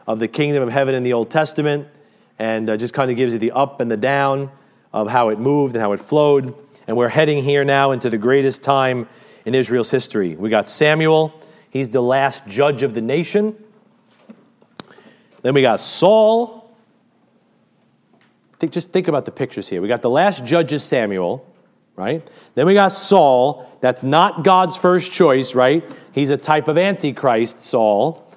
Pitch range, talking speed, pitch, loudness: 130-175 Hz, 180 wpm, 140 Hz, -17 LUFS